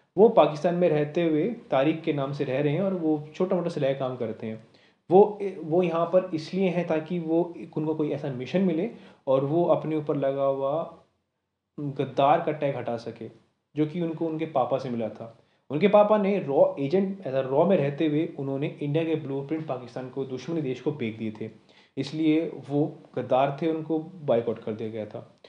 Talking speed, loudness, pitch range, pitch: 200 wpm, -26 LUFS, 135-170 Hz, 150 Hz